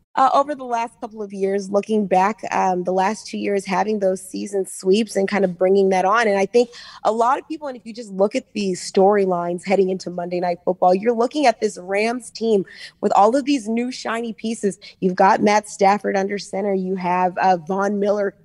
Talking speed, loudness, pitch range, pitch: 220 wpm, -20 LUFS, 190-220 Hz, 195 Hz